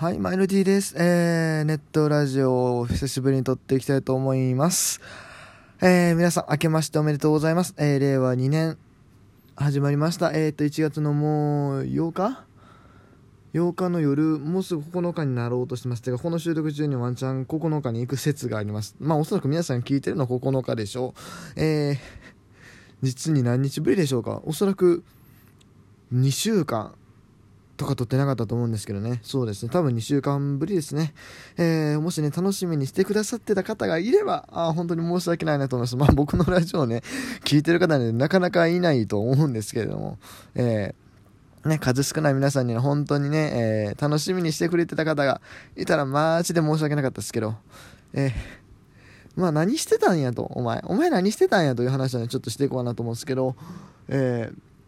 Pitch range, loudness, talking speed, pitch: 125-165 Hz, -24 LUFS, 390 characters per minute, 145 Hz